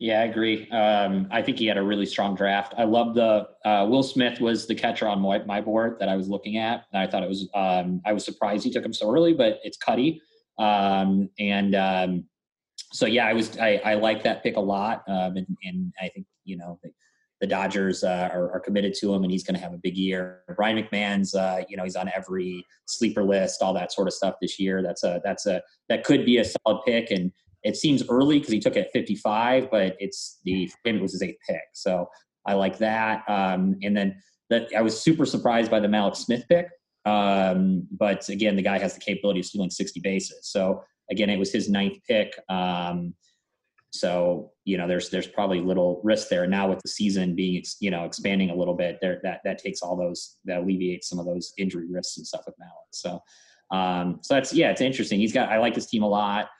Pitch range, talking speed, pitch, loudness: 95-110 Hz, 235 wpm, 100 Hz, -25 LUFS